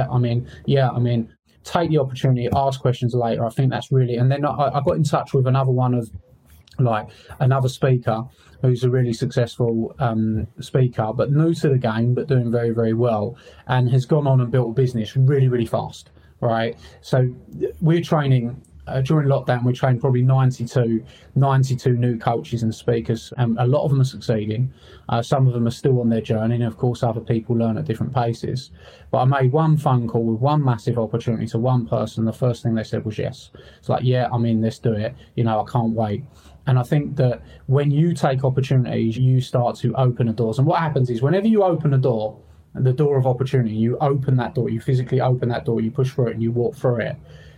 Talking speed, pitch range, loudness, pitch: 220 wpm, 115-135 Hz, -20 LUFS, 125 Hz